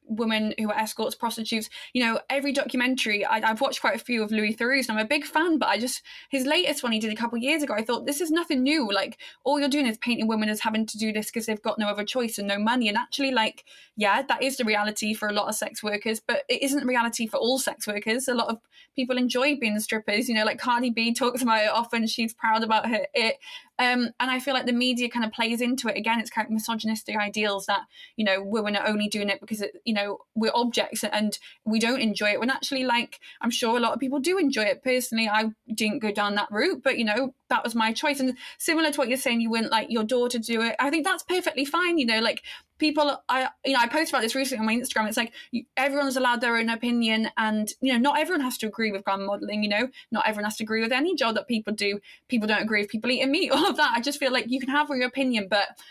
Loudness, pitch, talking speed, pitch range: -25 LUFS, 235 Hz, 270 wpm, 220-265 Hz